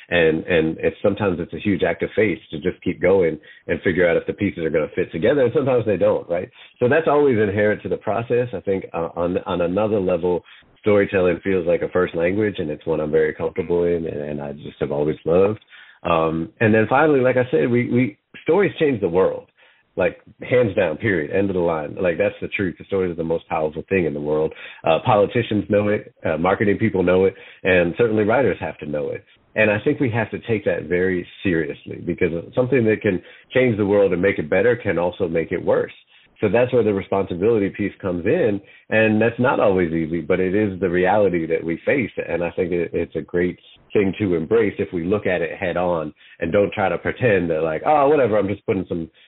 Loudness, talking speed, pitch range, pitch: -20 LUFS, 235 wpm, 90-125 Hz, 100 Hz